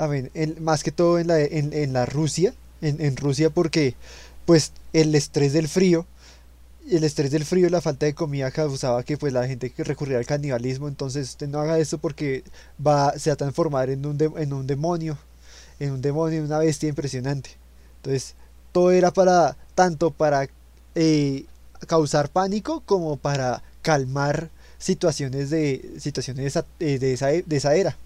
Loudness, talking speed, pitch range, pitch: -23 LUFS, 180 wpm, 135-160 Hz, 150 Hz